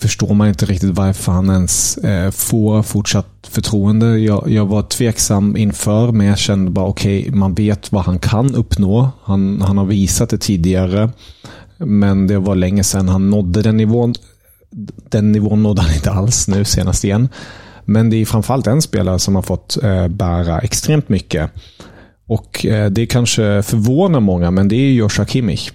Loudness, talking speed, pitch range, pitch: -14 LUFS, 165 wpm, 95-110 Hz, 105 Hz